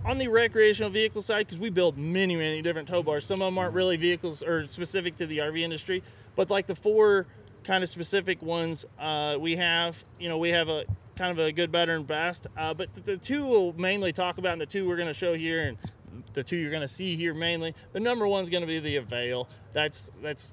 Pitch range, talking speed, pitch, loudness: 155-190 Hz, 245 wpm, 170 Hz, -28 LUFS